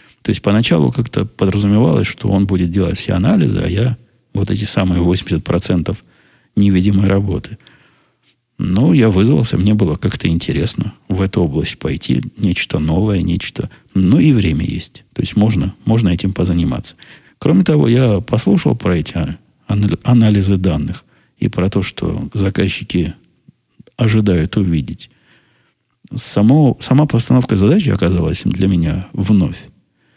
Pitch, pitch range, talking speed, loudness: 100 Hz, 90-115 Hz, 135 wpm, -15 LUFS